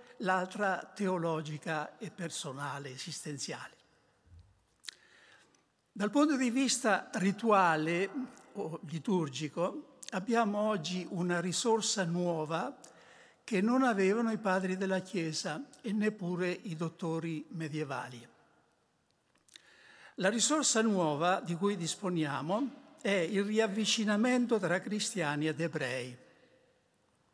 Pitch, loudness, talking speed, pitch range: 185 Hz, -33 LUFS, 90 wpm, 165-215 Hz